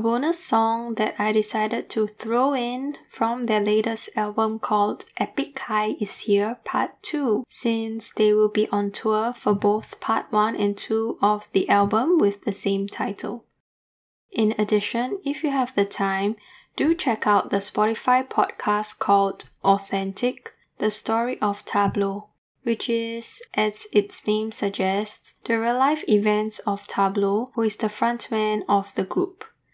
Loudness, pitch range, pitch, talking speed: -23 LUFS, 205-235 Hz, 215 Hz, 155 wpm